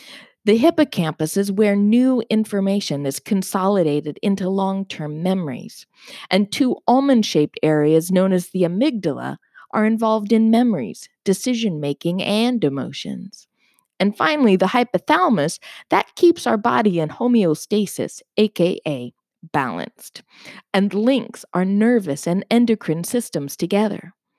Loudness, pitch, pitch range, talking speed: -19 LUFS, 200 Hz, 175-230 Hz, 120 wpm